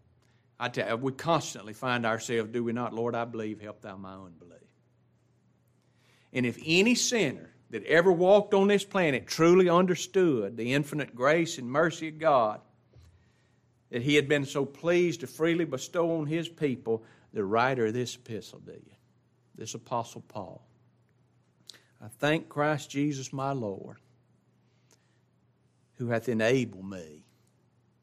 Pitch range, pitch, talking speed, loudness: 115-160 Hz, 125 Hz, 145 wpm, -28 LUFS